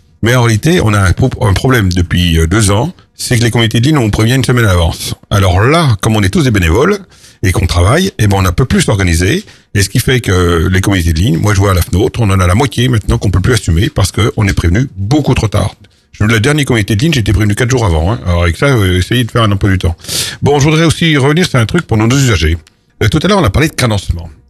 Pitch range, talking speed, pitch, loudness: 95-125 Hz, 280 wpm, 110 Hz, -11 LUFS